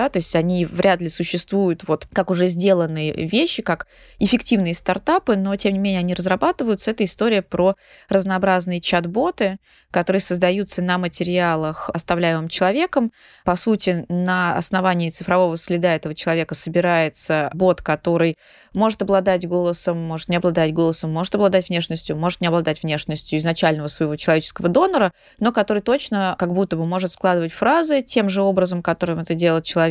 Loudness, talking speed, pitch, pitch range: -20 LUFS, 155 wpm, 180 Hz, 170-195 Hz